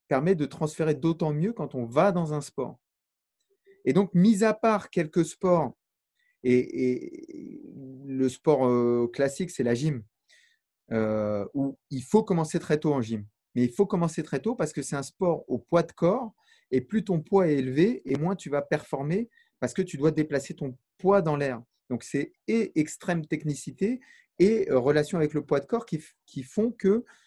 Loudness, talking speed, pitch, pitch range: -27 LUFS, 190 wpm, 160 Hz, 140-200 Hz